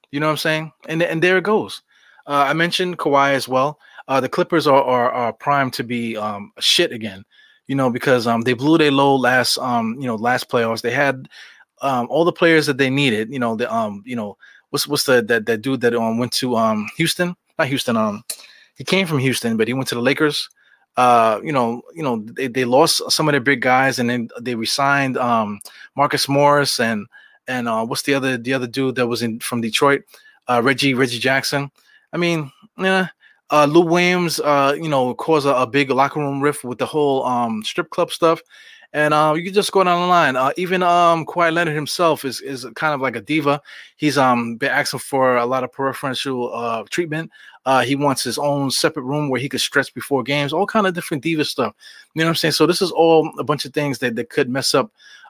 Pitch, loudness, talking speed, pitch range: 140 Hz, -18 LUFS, 230 wpm, 125-160 Hz